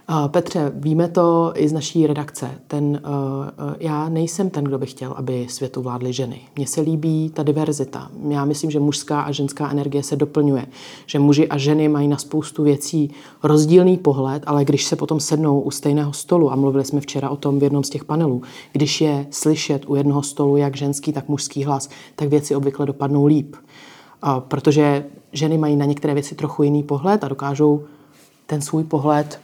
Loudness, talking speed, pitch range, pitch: -19 LUFS, 195 wpm, 140-150 Hz, 145 Hz